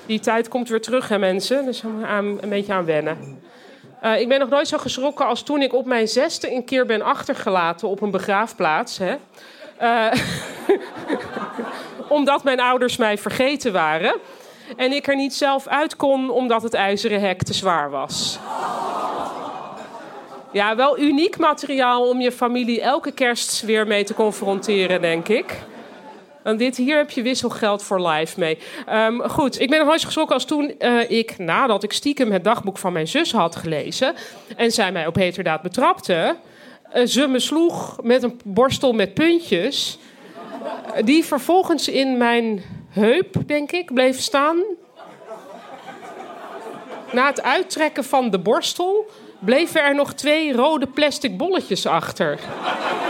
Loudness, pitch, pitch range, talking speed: -20 LUFS, 250 Hz, 210-285 Hz, 155 wpm